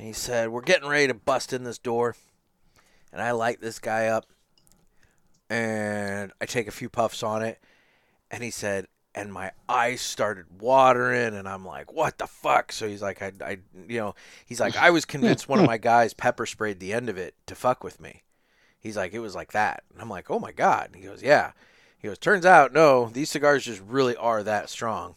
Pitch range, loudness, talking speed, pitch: 105-120 Hz, -24 LUFS, 220 wpm, 115 Hz